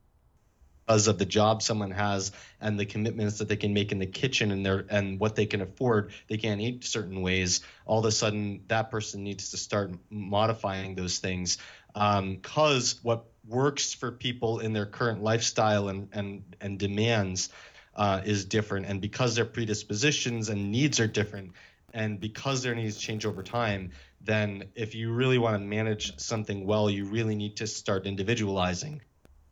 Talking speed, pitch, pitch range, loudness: 175 wpm, 105 Hz, 100-115 Hz, -29 LUFS